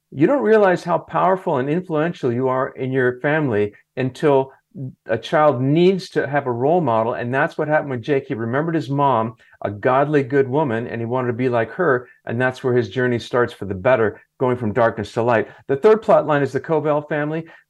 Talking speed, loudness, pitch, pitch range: 215 wpm, -19 LUFS, 135 Hz, 125-155 Hz